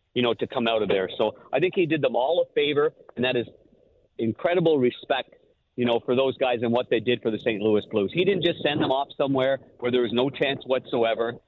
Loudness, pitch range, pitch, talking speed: -24 LUFS, 120-155 Hz, 125 Hz, 250 wpm